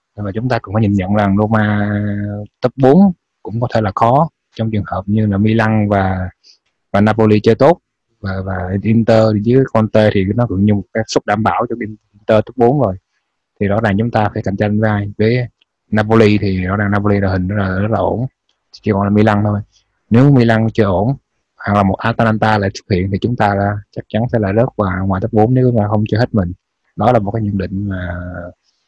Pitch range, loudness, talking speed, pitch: 100-115 Hz, -15 LUFS, 235 wpm, 105 Hz